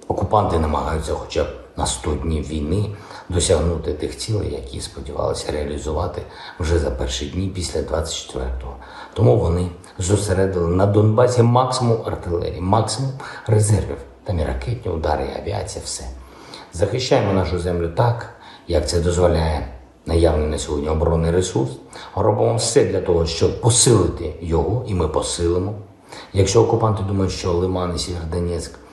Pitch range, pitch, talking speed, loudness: 80-105 Hz, 90 Hz, 135 wpm, -20 LUFS